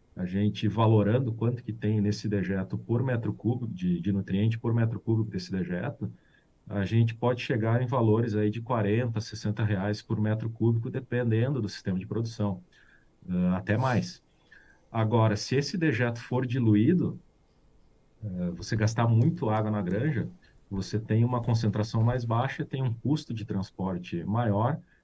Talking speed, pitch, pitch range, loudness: 160 wpm, 110 Hz, 105-120 Hz, -28 LUFS